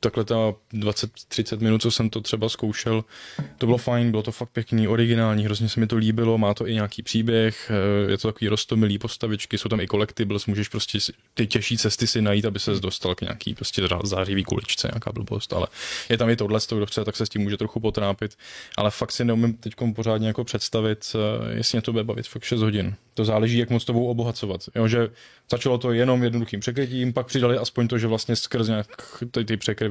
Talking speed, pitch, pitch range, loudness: 210 wpm, 110 Hz, 105-120 Hz, -24 LUFS